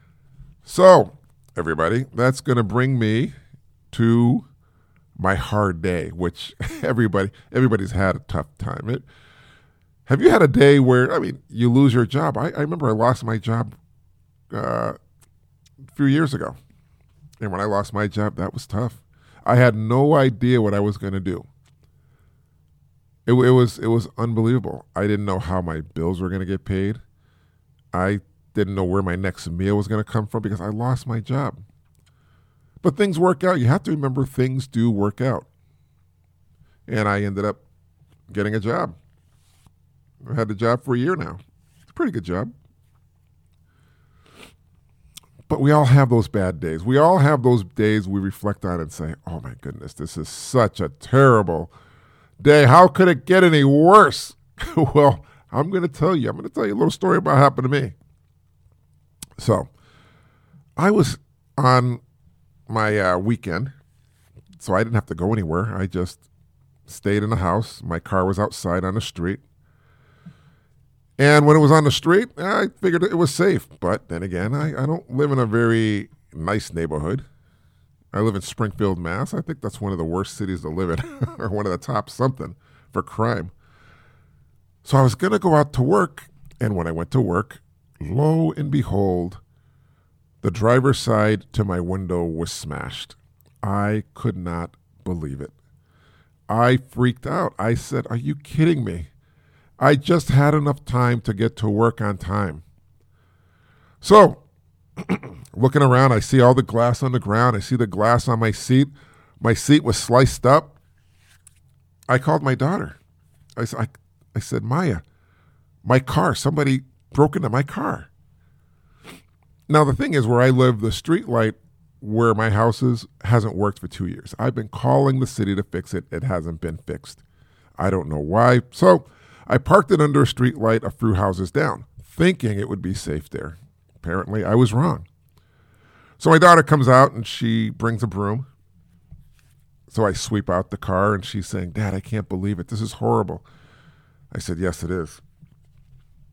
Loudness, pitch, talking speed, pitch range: -20 LUFS, 110 Hz, 175 wpm, 95-130 Hz